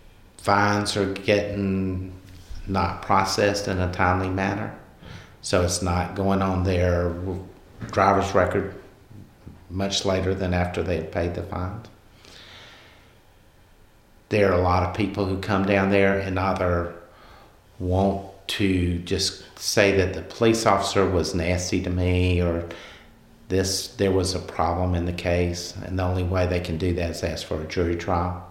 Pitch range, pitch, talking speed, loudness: 90-100 Hz, 95 Hz, 155 wpm, -24 LUFS